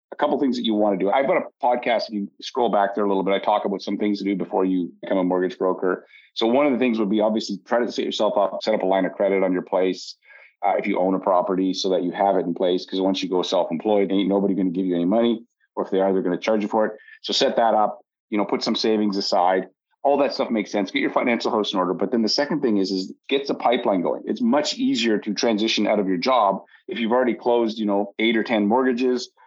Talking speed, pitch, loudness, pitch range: 295 wpm, 100 Hz, -22 LUFS, 95-110 Hz